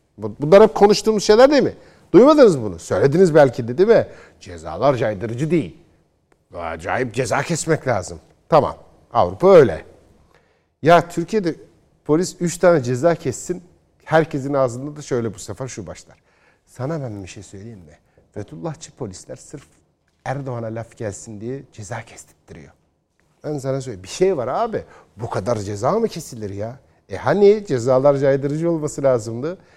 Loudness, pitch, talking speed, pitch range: -17 LUFS, 135 Hz, 145 wpm, 115-160 Hz